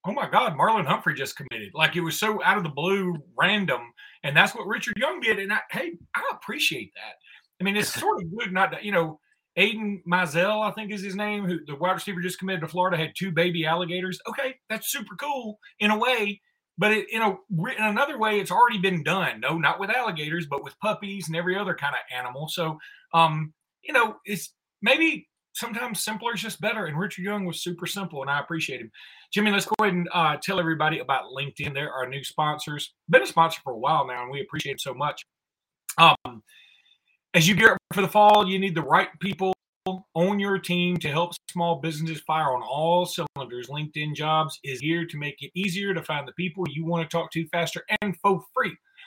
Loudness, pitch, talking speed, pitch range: -25 LUFS, 180 Hz, 225 wpm, 160-210 Hz